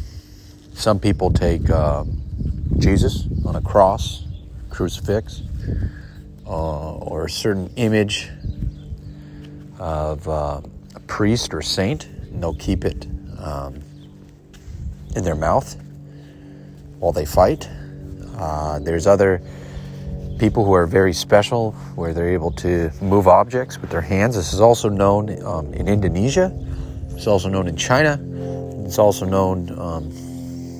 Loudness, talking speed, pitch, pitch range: -20 LUFS, 125 wpm, 90 Hz, 75-100 Hz